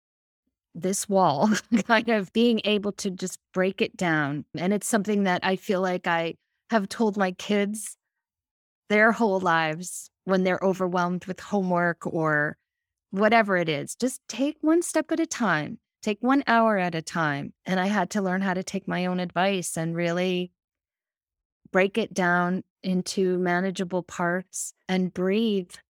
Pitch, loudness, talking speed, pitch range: 185 Hz, -25 LUFS, 160 wpm, 180-215 Hz